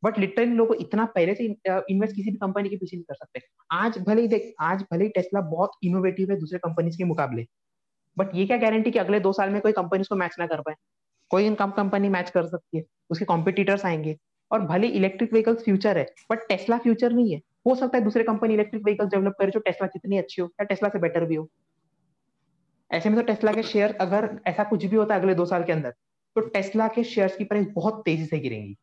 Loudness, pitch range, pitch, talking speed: -24 LUFS, 175-215 Hz, 195 Hz, 240 wpm